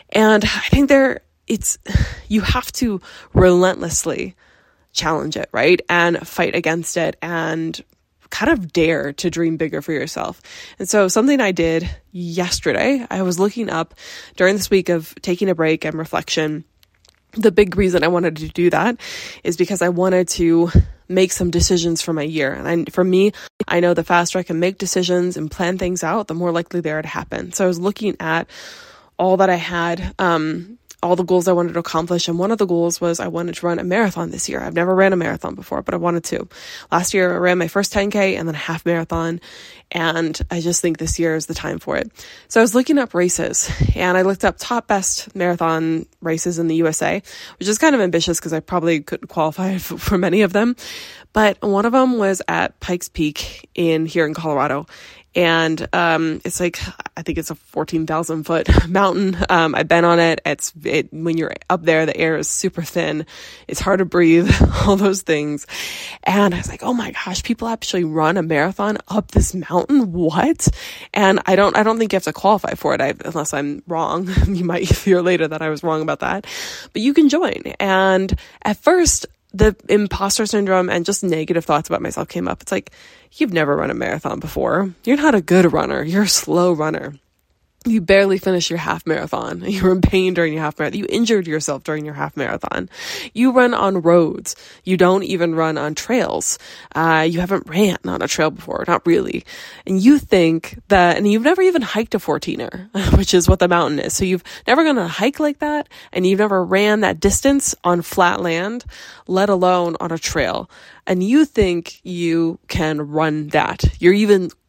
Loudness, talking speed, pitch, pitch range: -18 LUFS, 205 wpm, 180 Hz, 165-200 Hz